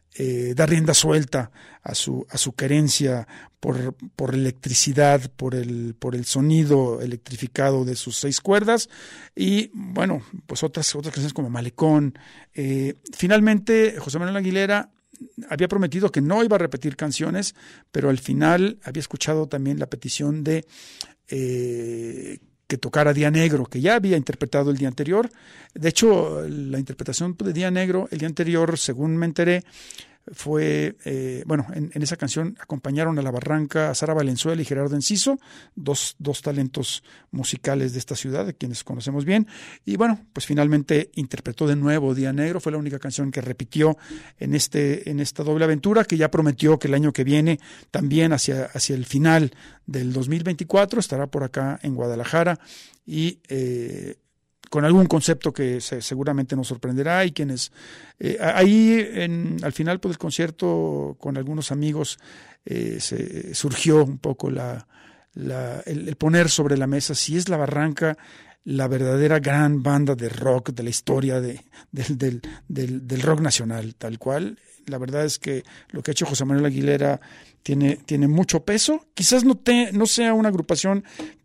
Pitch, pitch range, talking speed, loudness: 150 Hz, 135-165 Hz, 170 wpm, -22 LUFS